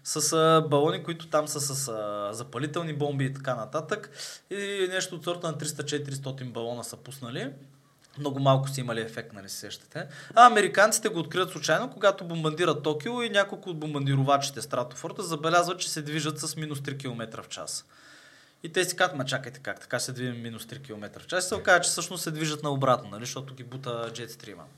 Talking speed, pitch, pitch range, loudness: 190 wpm, 150 Hz, 125-170 Hz, -27 LUFS